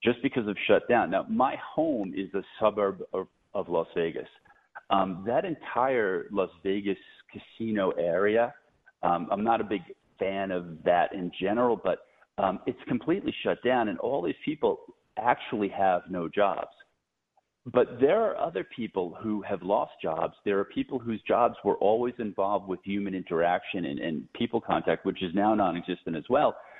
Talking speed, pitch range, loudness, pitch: 170 wpm, 95-110 Hz, -29 LUFS, 100 Hz